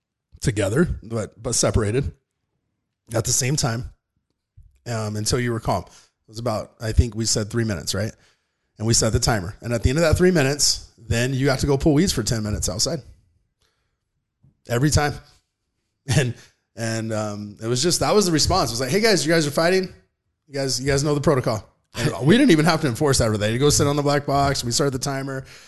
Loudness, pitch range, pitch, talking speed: -21 LUFS, 110-145 Hz, 120 Hz, 220 wpm